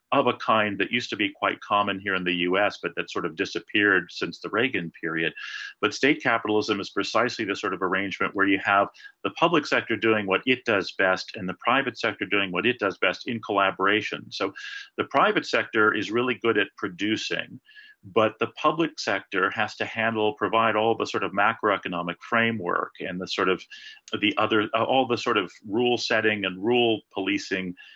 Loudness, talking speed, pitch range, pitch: -25 LUFS, 195 wpm, 100-120 Hz, 110 Hz